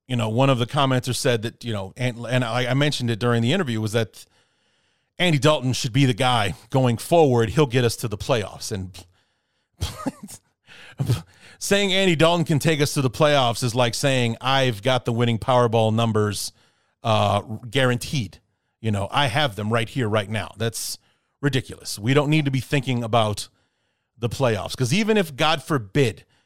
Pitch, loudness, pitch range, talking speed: 125 Hz, -22 LUFS, 115-140 Hz, 185 wpm